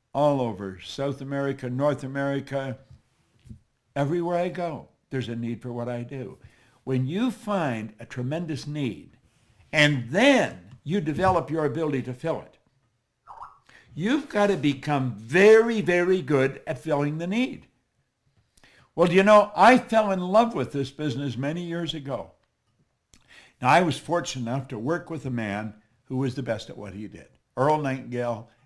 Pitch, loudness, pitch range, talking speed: 140 Hz, -25 LUFS, 125-170 Hz, 160 wpm